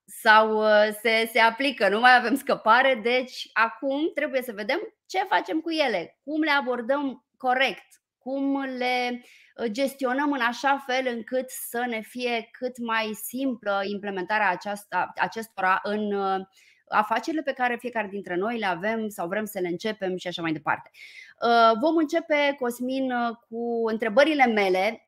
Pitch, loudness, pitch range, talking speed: 235 Hz, -25 LUFS, 215-270 Hz, 145 wpm